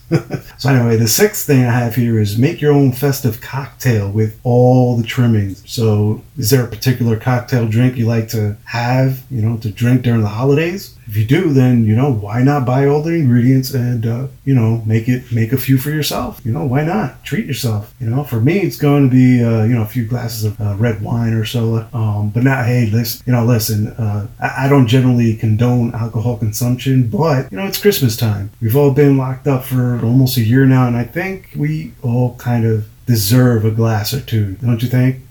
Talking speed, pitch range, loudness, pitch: 225 wpm, 115-130 Hz, -15 LUFS, 120 Hz